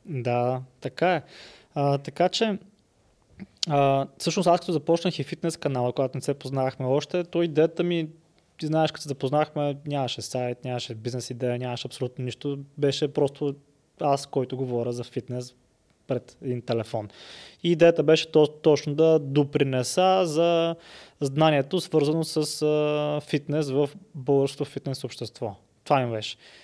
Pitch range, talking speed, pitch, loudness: 130-160 Hz, 145 wpm, 145 Hz, -26 LUFS